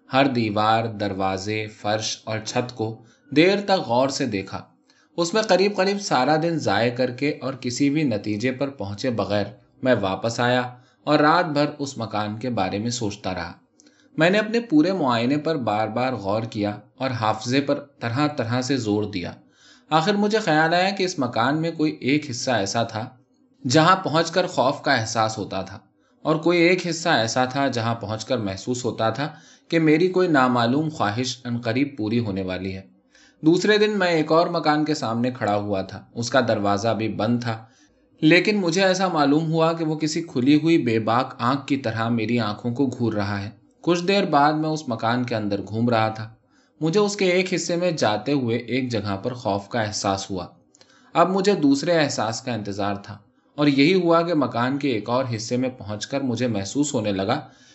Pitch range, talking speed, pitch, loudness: 110-155 Hz, 195 wpm, 125 Hz, -22 LUFS